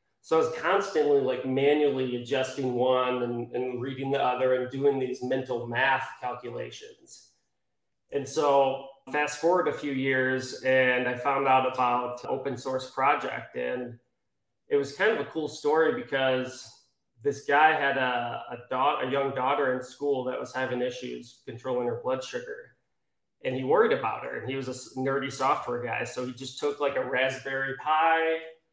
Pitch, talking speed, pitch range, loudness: 130 Hz, 170 wpm, 125-140 Hz, -28 LUFS